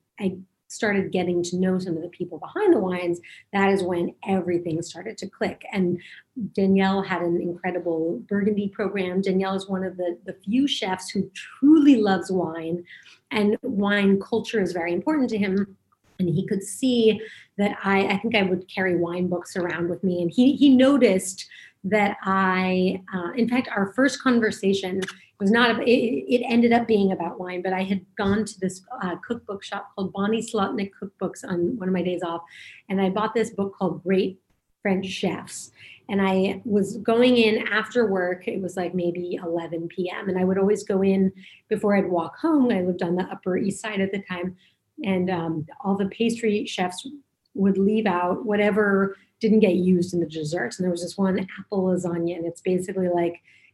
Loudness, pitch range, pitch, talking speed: -24 LUFS, 180-210 Hz, 195 Hz, 190 wpm